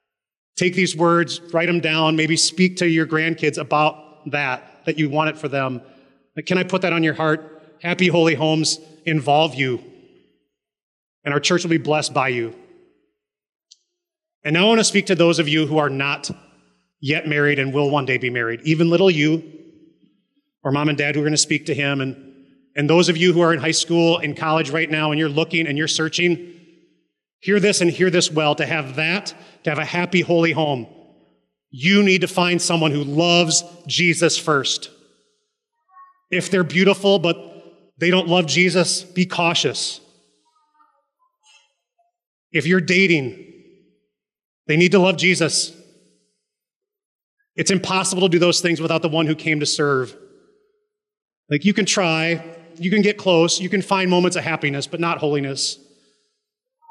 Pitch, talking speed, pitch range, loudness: 165 Hz, 175 wpm, 150-185 Hz, -18 LUFS